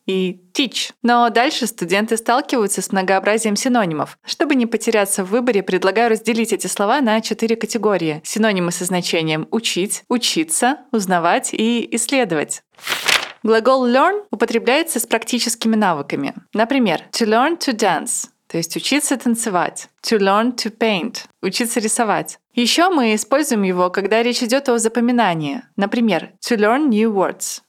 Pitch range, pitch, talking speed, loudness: 200-245 Hz, 225 Hz, 140 wpm, -18 LUFS